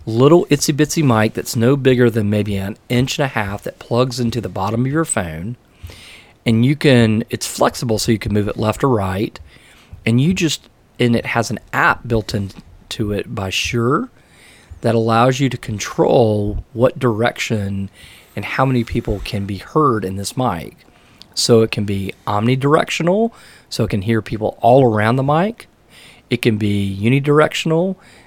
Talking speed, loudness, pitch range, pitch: 175 wpm, -17 LUFS, 105-130 Hz, 115 Hz